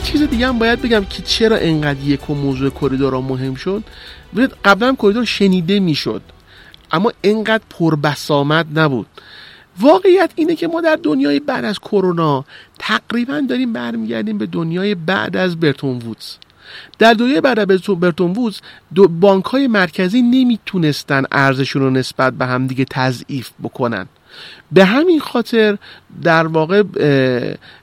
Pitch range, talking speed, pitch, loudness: 140-235 Hz, 140 wpm, 190 Hz, -15 LUFS